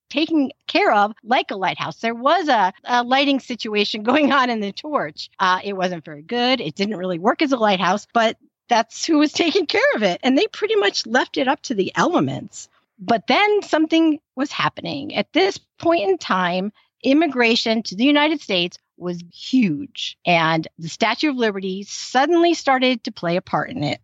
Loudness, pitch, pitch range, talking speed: -19 LUFS, 245 Hz, 200-295 Hz, 190 wpm